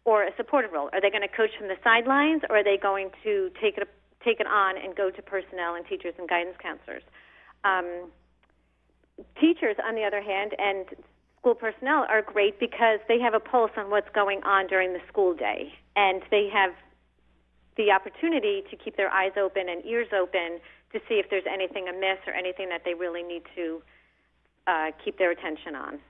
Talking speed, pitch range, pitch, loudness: 200 wpm, 180-220 Hz, 195 Hz, -26 LUFS